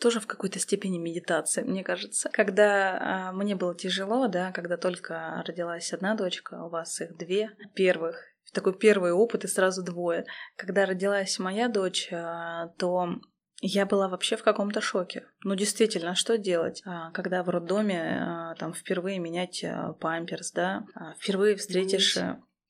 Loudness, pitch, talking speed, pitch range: -28 LUFS, 185 Hz, 155 wpm, 175-200 Hz